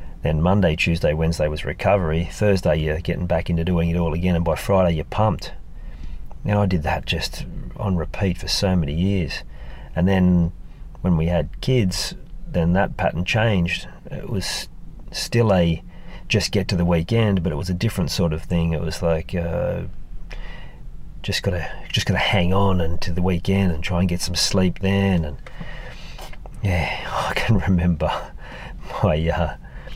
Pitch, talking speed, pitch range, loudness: 85 Hz, 170 wpm, 85-95 Hz, -21 LUFS